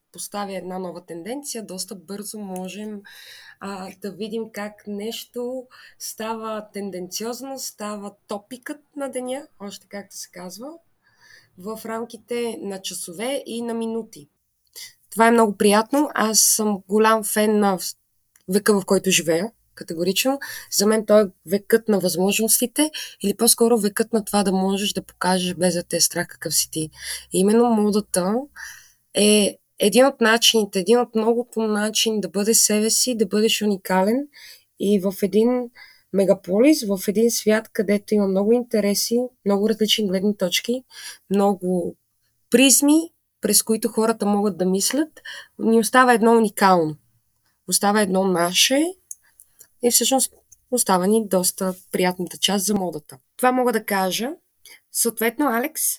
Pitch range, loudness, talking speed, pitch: 190-230 Hz, -20 LUFS, 140 wpm, 210 Hz